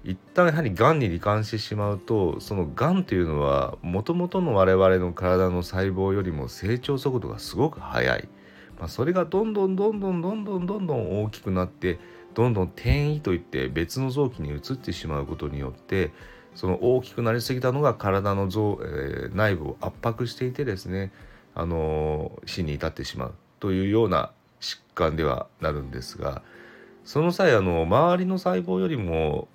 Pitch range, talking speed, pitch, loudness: 90-135 Hz, 355 characters per minute, 100 Hz, -25 LUFS